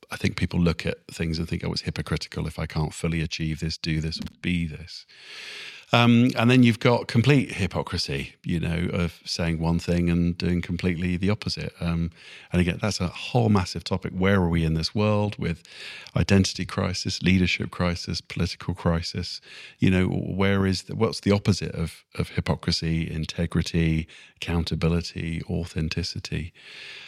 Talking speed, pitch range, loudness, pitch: 170 wpm, 85-95 Hz, -25 LUFS, 85 Hz